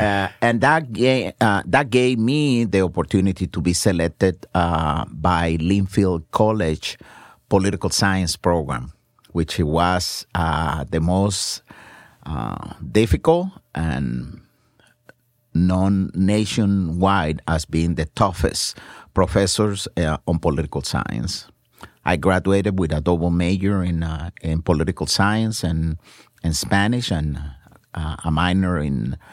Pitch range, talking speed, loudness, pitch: 80-100 Hz, 120 wpm, -20 LUFS, 90 Hz